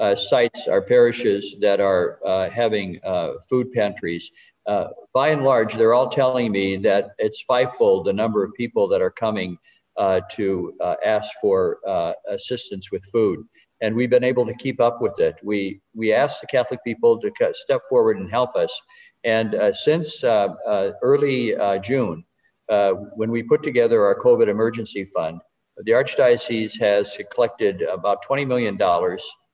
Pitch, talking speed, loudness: 130 Hz, 170 wpm, -21 LUFS